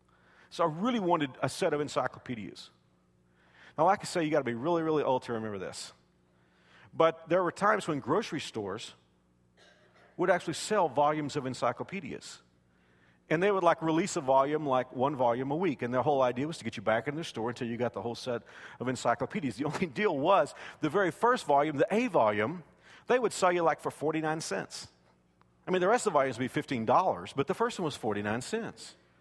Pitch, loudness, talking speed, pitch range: 140 Hz, -30 LUFS, 210 wpm, 105-165 Hz